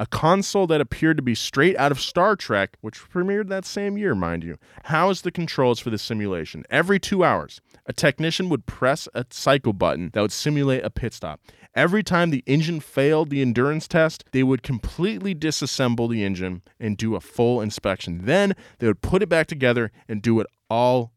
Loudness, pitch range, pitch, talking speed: -22 LUFS, 115-170 Hz, 135 Hz, 200 wpm